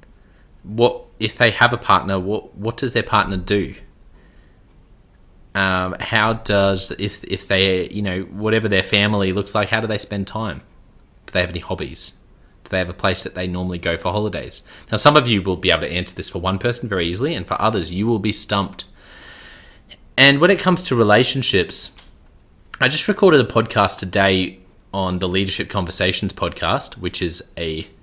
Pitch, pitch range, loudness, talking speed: 100 Hz, 95-110 Hz, -18 LUFS, 190 wpm